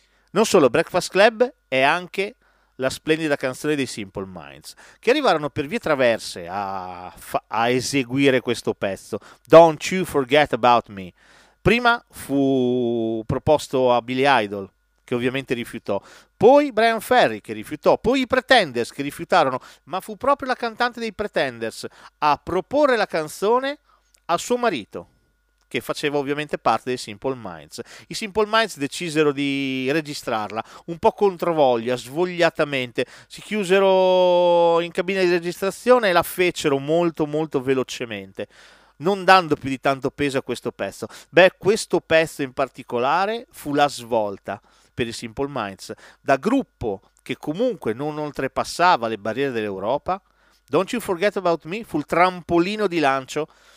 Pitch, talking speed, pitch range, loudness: 150 Hz, 145 wpm, 125-185 Hz, -21 LUFS